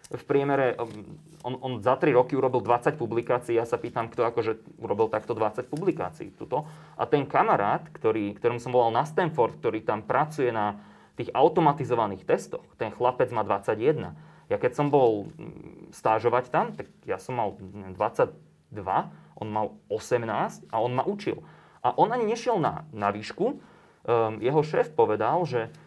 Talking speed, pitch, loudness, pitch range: 160 wpm, 125 Hz, -27 LUFS, 110-155 Hz